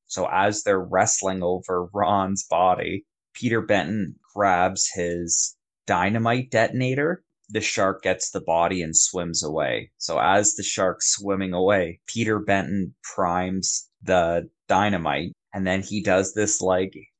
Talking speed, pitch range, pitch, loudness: 135 wpm, 90-105 Hz, 95 Hz, -23 LUFS